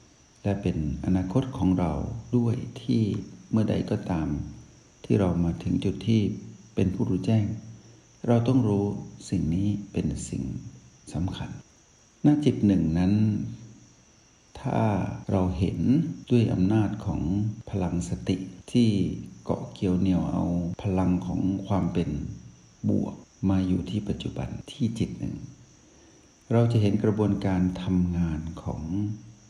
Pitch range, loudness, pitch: 90-110 Hz, -27 LUFS, 95 Hz